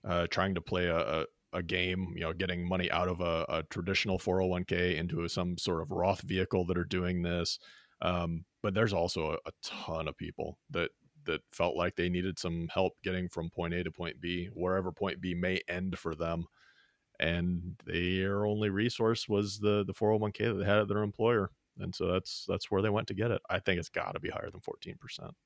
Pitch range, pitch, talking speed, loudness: 85-95 Hz, 90 Hz, 215 wpm, -33 LUFS